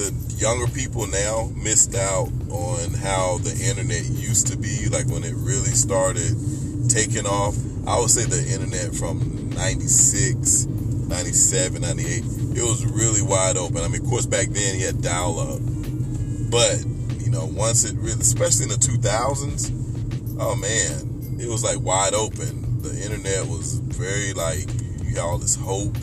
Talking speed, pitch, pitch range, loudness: 160 wpm, 120 Hz, 115-125 Hz, -21 LUFS